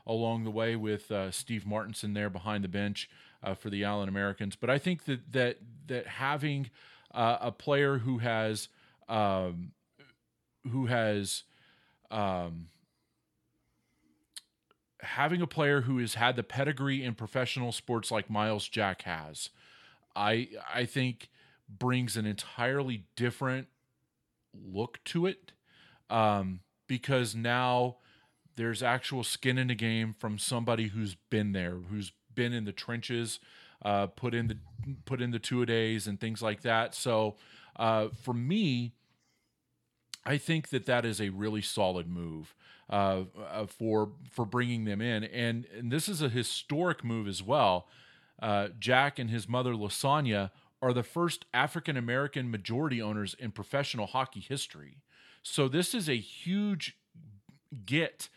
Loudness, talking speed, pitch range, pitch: -32 LUFS, 145 wpm, 105-130 Hz, 115 Hz